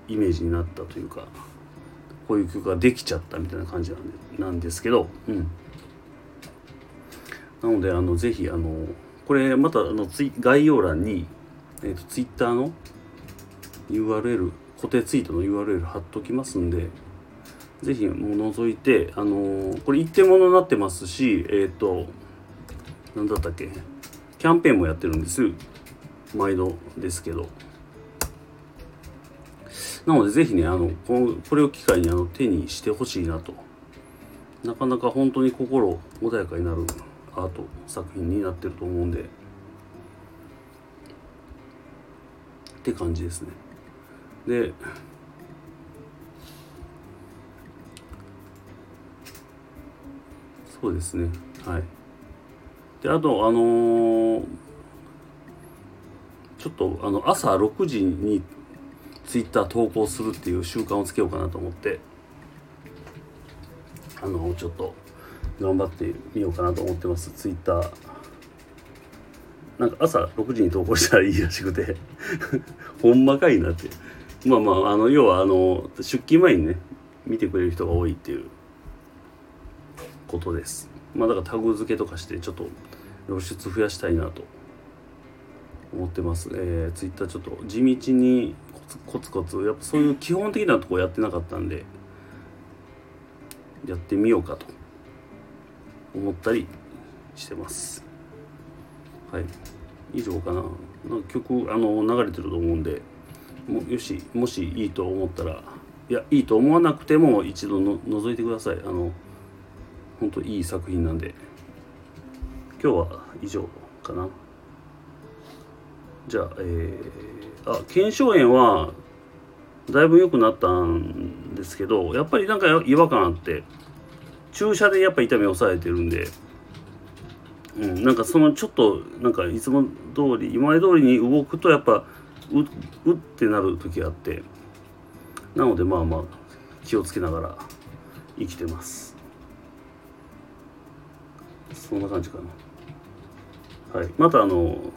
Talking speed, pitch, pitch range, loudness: 255 characters per minute, 95 Hz, 85-130 Hz, -23 LUFS